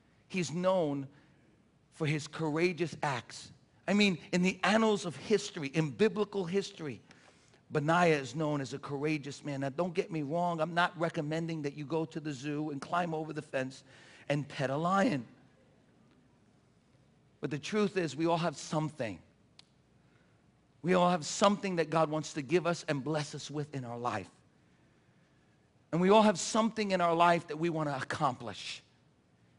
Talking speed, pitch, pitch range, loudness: 170 wpm, 155 Hz, 145-175 Hz, -32 LUFS